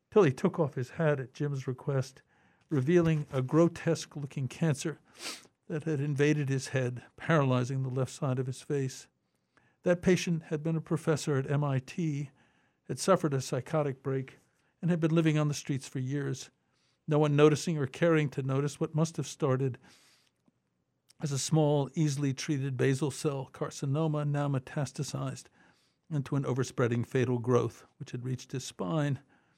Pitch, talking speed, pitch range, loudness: 145 Hz, 160 wpm, 130-155 Hz, -31 LUFS